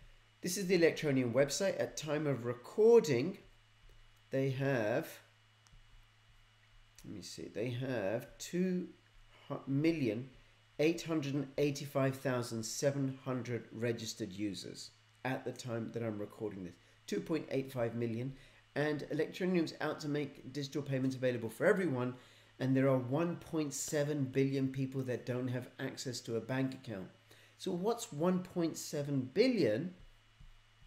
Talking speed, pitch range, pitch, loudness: 110 wpm, 115-145 Hz, 130 Hz, -36 LUFS